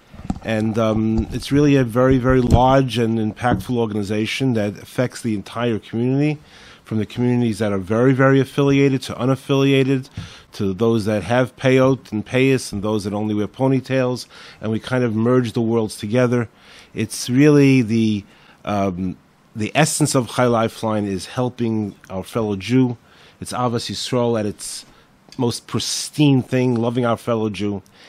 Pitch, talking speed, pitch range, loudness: 120 Hz, 165 wpm, 105-130 Hz, -19 LUFS